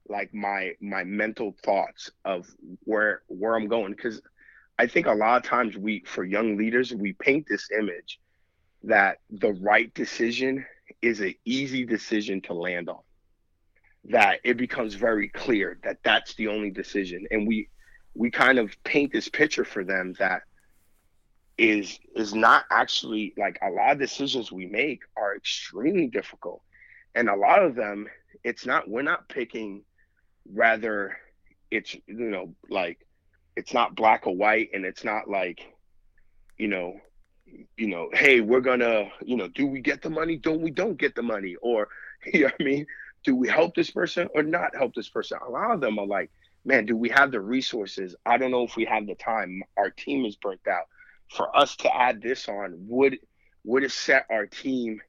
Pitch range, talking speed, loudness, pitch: 105-130 Hz, 185 wpm, -25 LUFS, 115 Hz